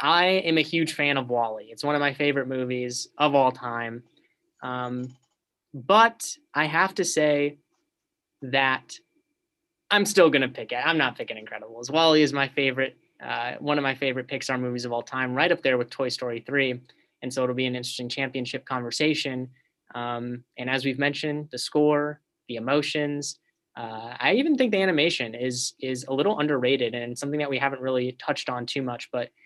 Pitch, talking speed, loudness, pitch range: 135 Hz, 190 wpm, -25 LUFS, 125-155 Hz